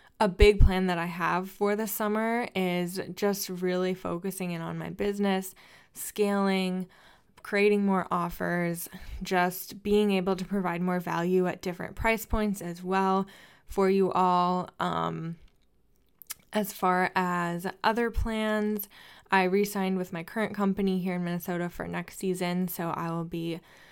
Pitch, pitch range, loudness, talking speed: 185 Hz, 175-200 Hz, -28 LUFS, 150 wpm